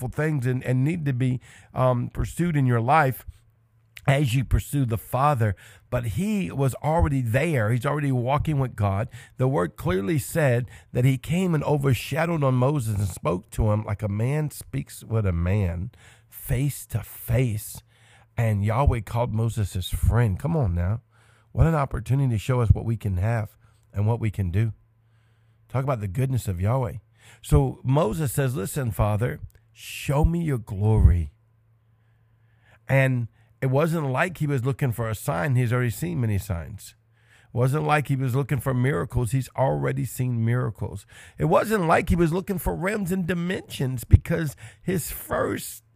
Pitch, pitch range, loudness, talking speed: 120 Hz, 110-140 Hz, -25 LUFS, 170 wpm